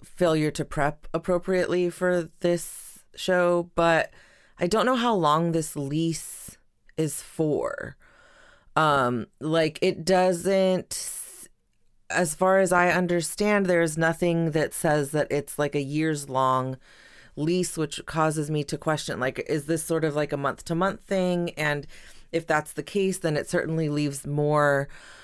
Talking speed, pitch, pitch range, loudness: 150 wpm, 160 Hz, 150-180 Hz, -25 LUFS